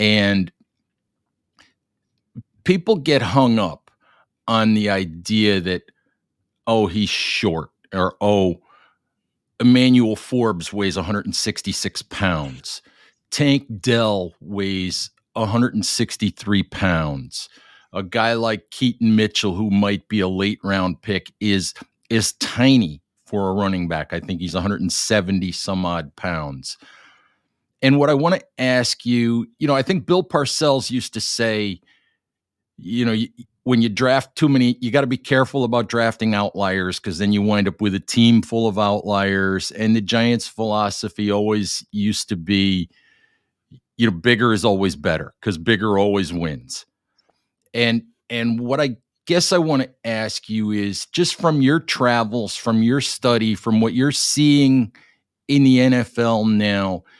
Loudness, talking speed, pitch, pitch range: -19 LUFS, 145 wpm, 110 Hz, 100-120 Hz